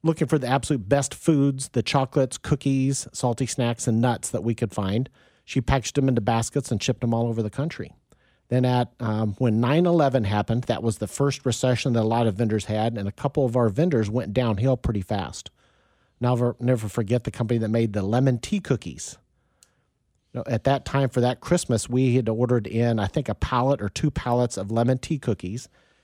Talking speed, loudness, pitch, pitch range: 210 wpm, -24 LUFS, 125 Hz, 115-135 Hz